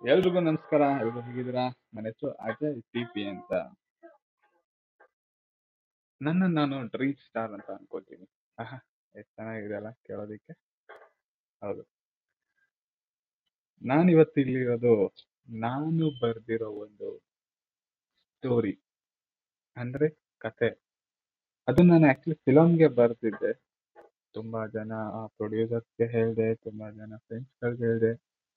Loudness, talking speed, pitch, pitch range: -27 LUFS, 85 wpm, 120 Hz, 110-155 Hz